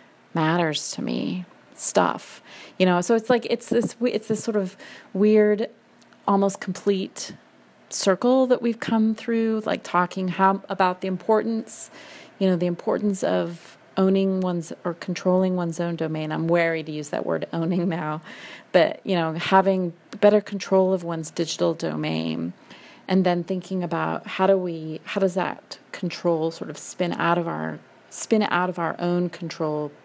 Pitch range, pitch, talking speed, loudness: 170-210 Hz, 185 Hz, 165 wpm, -24 LUFS